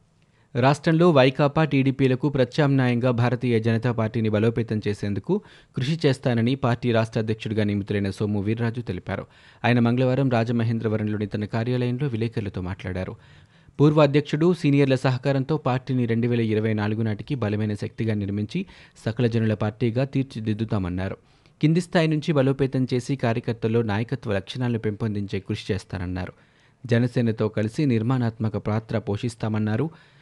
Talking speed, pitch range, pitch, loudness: 115 wpm, 110-135 Hz, 120 Hz, -24 LUFS